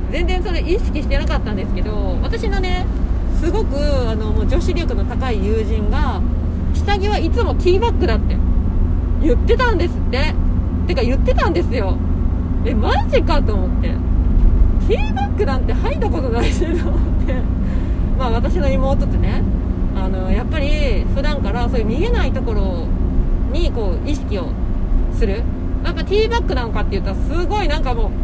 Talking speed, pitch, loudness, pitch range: 340 characters per minute, 85 Hz, -19 LUFS, 85-90 Hz